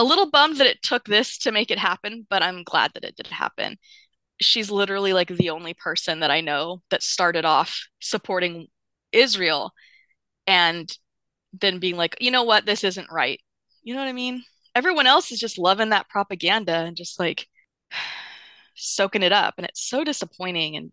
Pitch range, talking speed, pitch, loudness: 175-245 Hz, 185 wpm, 195 Hz, -21 LUFS